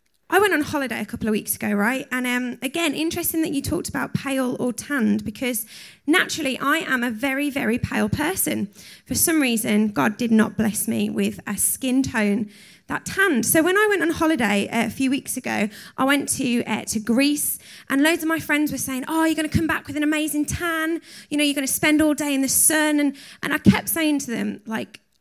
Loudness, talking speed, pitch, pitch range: -21 LUFS, 230 wpm, 270 Hz, 225-305 Hz